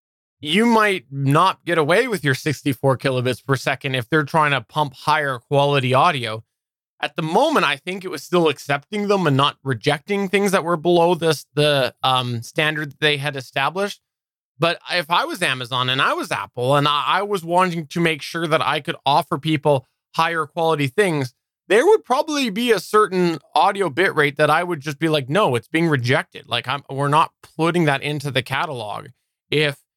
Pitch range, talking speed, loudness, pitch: 140-175 Hz, 190 wpm, -19 LUFS, 155 Hz